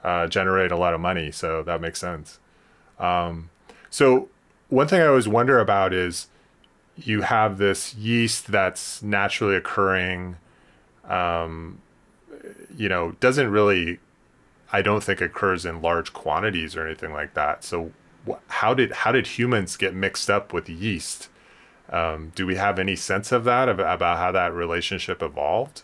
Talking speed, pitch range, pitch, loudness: 160 wpm, 85-100 Hz, 90 Hz, -23 LUFS